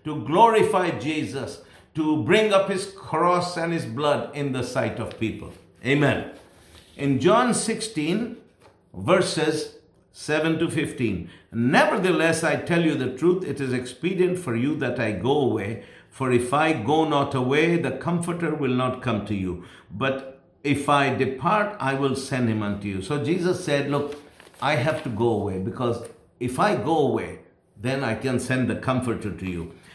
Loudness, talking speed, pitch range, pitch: -24 LUFS, 170 wpm, 125-165 Hz, 140 Hz